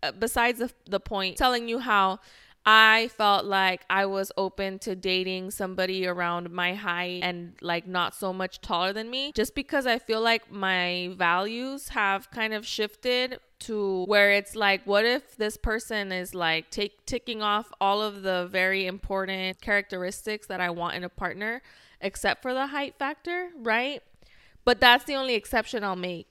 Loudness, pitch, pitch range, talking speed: -26 LUFS, 200 Hz, 185-230 Hz, 175 wpm